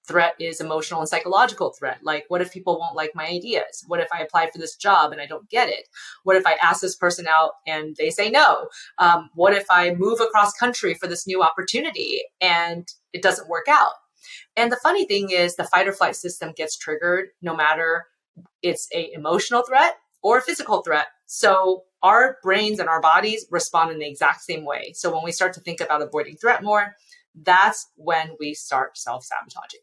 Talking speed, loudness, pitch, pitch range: 205 wpm, -21 LUFS, 175 Hz, 165-205 Hz